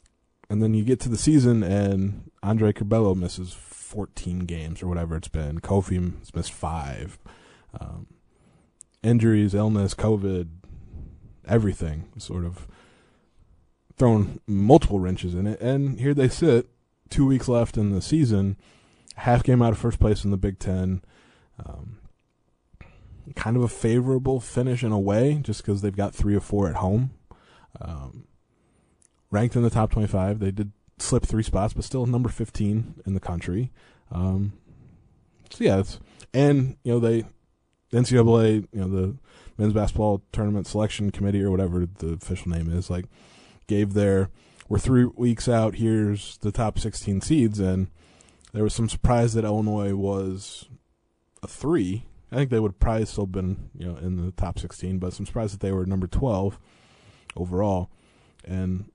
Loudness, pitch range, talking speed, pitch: -24 LUFS, 95-115 Hz, 160 wpm, 100 Hz